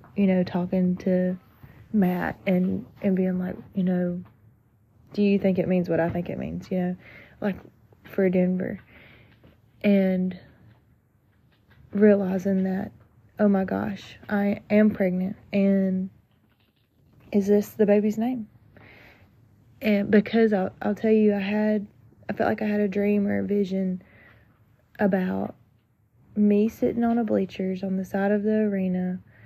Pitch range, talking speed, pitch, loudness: 140-205 Hz, 145 wpm, 190 Hz, -25 LUFS